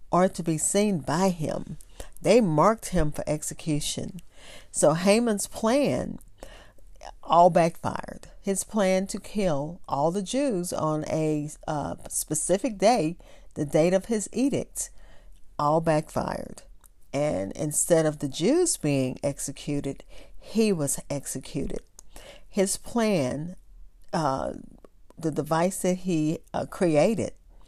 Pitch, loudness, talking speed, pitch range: 170 Hz, -26 LUFS, 115 wpm, 150-195 Hz